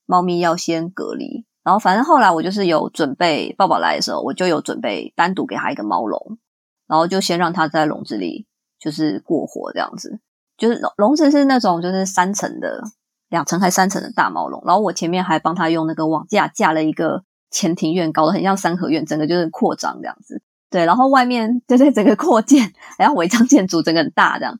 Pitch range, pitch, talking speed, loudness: 165-240 Hz, 185 Hz, 330 characters per minute, -17 LUFS